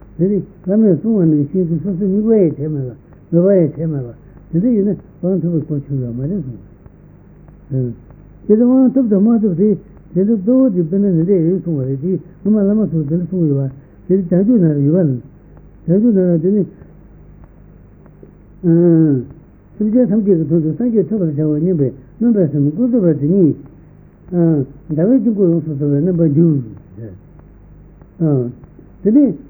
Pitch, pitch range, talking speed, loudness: 170 Hz, 150-200 Hz, 120 wpm, -15 LUFS